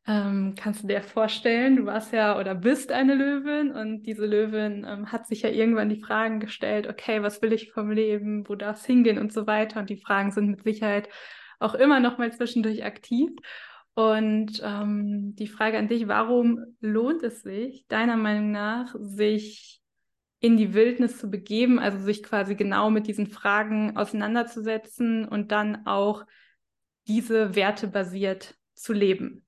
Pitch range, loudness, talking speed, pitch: 210-230 Hz, -25 LUFS, 165 wpm, 220 Hz